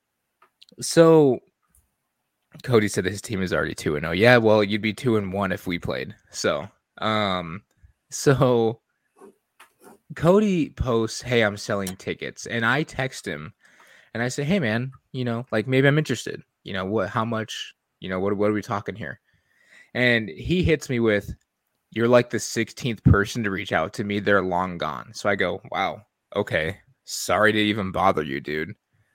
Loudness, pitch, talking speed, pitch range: -23 LUFS, 110 Hz, 180 wpm, 100-125 Hz